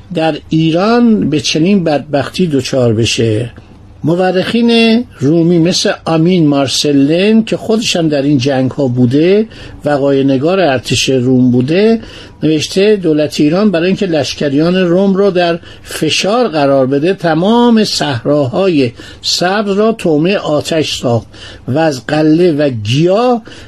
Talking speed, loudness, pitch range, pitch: 125 wpm, -11 LUFS, 140-185 Hz, 160 Hz